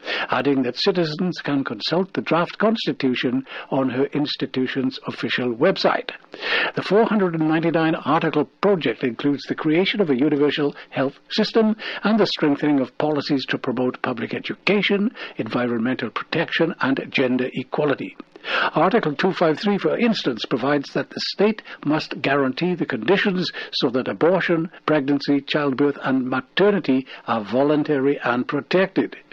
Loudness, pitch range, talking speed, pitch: -21 LUFS, 135-180 Hz, 125 wpm, 150 Hz